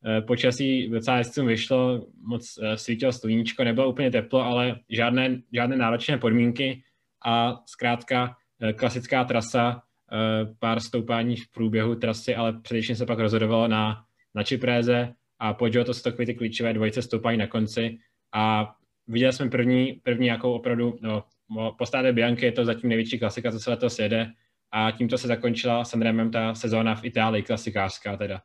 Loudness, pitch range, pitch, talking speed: -25 LUFS, 110-125 Hz, 120 Hz, 150 wpm